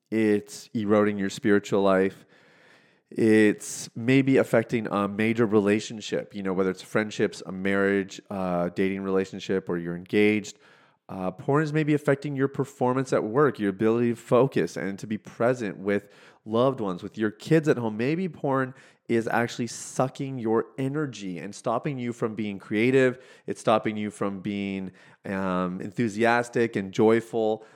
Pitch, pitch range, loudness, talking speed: 110 Hz, 100-125 Hz, -26 LUFS, 155 wpm